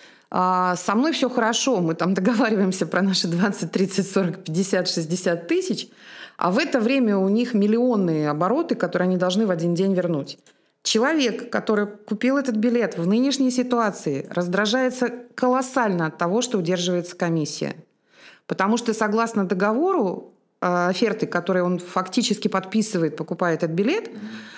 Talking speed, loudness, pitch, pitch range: 140 wpm, -22 LUFS, 200 Hz, 180-235 Hz